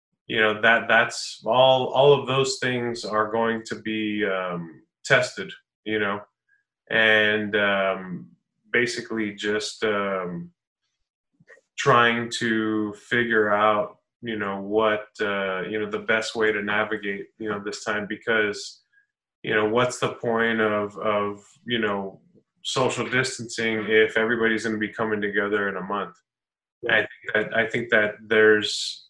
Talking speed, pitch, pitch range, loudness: 145 wpm, 110 Hz, 105-120 Hz, -23 LUFS